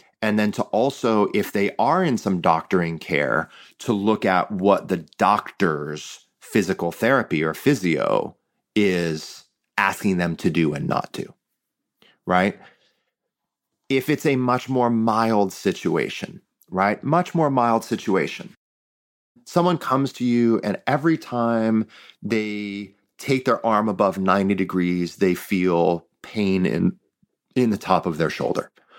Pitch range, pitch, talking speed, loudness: 95-125 Hz, 110 Hz, 135 wpm, -22 LUFS